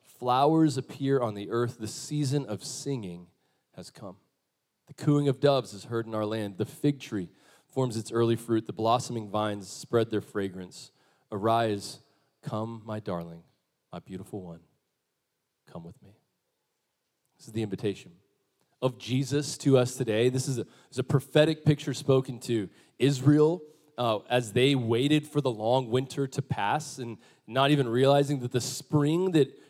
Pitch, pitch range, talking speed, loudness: 125 Hz, 110-140 Hz, 165 wpm, -28 LUFS